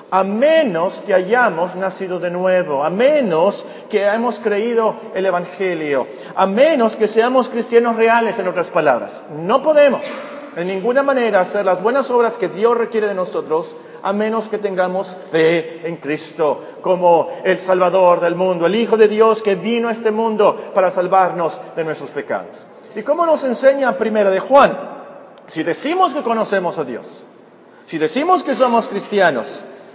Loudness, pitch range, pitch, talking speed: -16 LUFS, 185-245 Hz, 210 Hz, 160 wpm